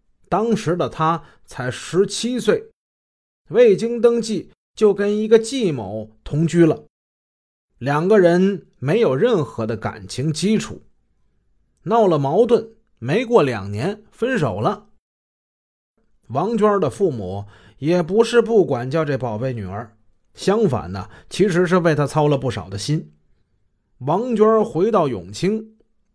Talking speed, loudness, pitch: 185 characters per minute, -19 LUFS, 165 Hz